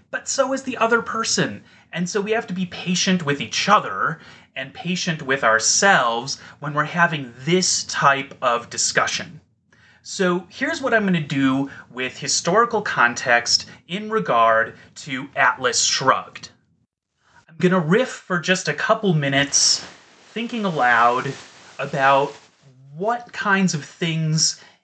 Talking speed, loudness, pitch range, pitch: 140 wpm, -20 LUFS, 135-195 Hz, 165 Hz